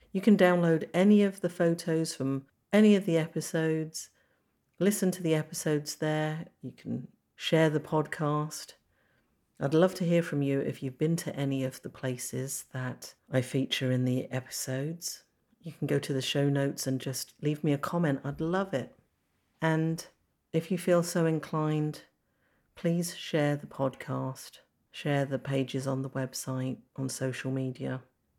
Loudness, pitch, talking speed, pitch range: -30 LUFS, 150 Hz, 165 wpm, 130-165 Hz